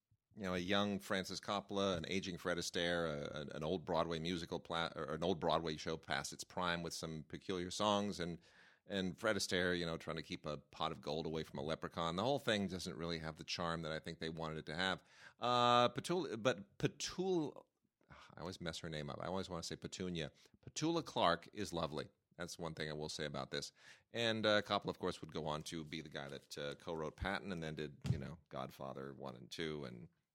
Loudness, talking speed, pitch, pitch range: -41 LUFS, 230 wpm, 85 Hz, 80-100 Hz